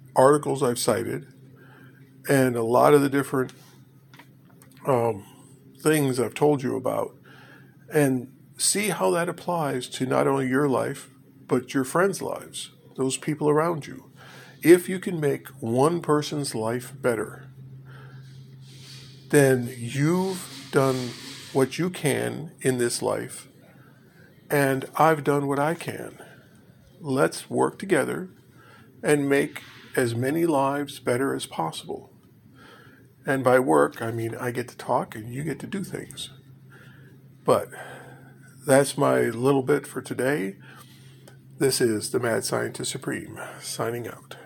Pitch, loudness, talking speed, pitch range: 135 Hz, -24 LUFS, 130 wpm, 130-145 Hz